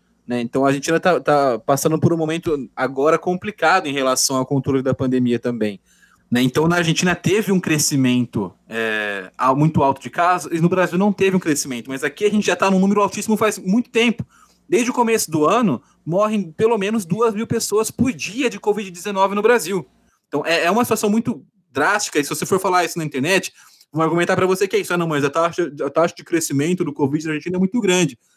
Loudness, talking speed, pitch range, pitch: -19 LUFS, 215 wpm, 140-205 Hz, 170 Hz